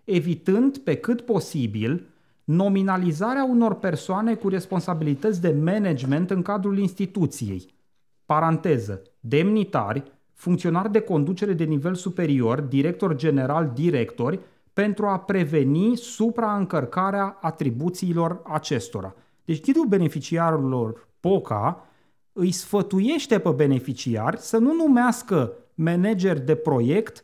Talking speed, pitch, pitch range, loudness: 100 wpm, 175 Hz, 150-200 Hz, -23 LUFS